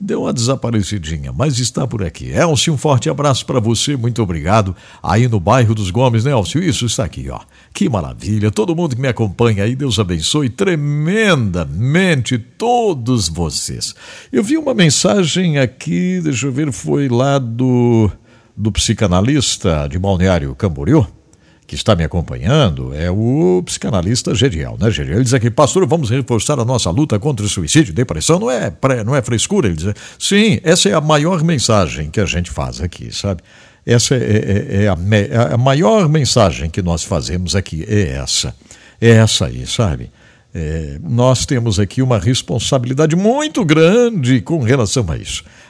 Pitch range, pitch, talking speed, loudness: 100-150 Hz, 120 Hz, 170 wpm, -15 LUFS